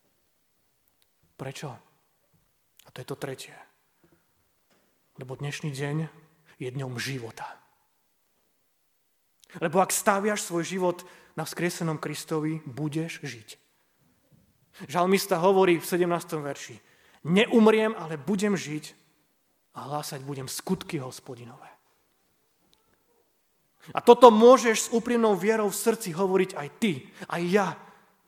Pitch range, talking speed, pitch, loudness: 145-195 Hz, 105 wpm, 170 Hz, -25 LUFS